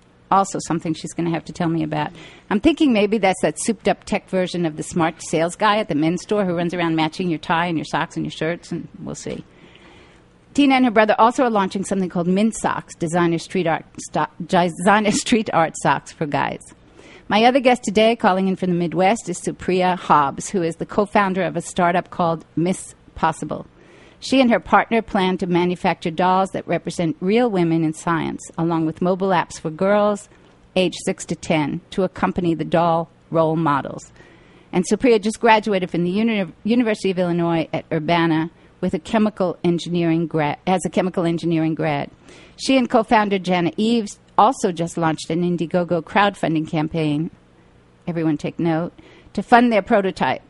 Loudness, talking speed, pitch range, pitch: -20 LUFS, 190 wpm, 165-205 Hz, 180 Hz